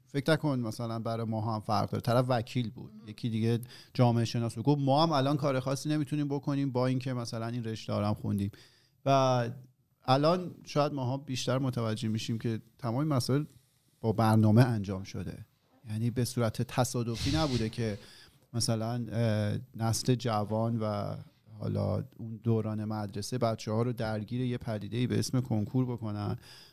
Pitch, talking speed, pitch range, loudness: 120 Hz, 155 wpm, 110-130 Hz, -31 LUFS